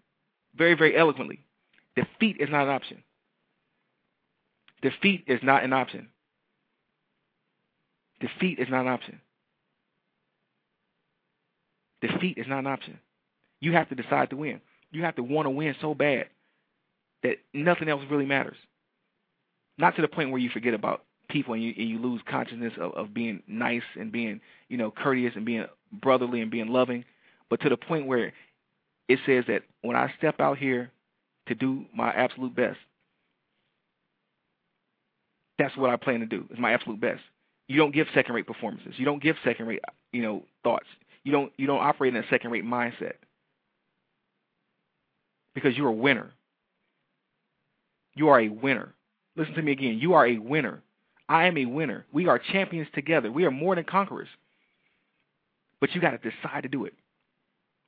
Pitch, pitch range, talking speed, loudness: 135 Hz, 120-155 Hz, 165 wpm, -27 LUFS